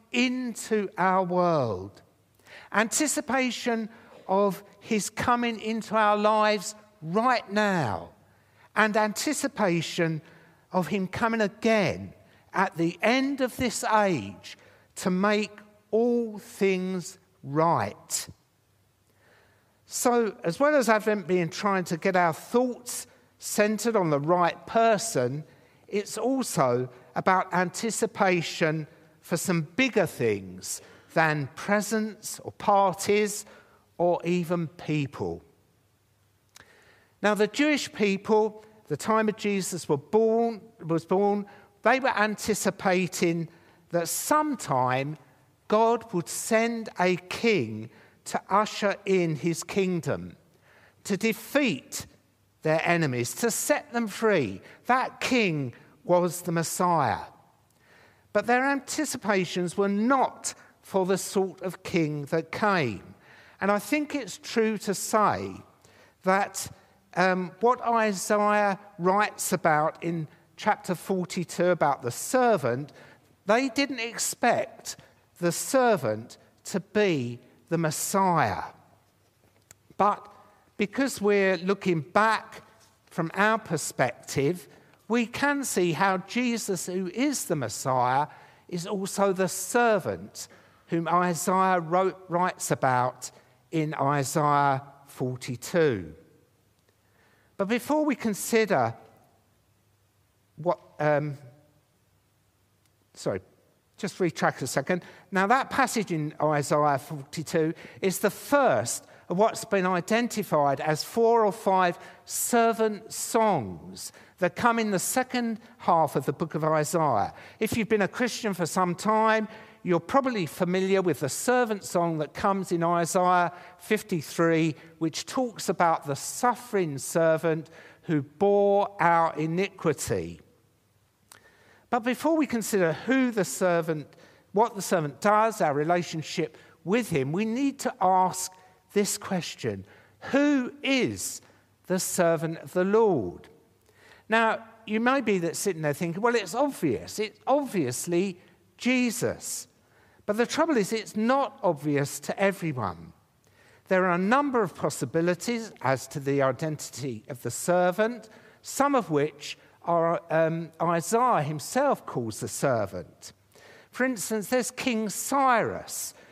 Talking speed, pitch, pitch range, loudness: 115 wpm, 185 Hz, 155-220 Hz, -26 LUFS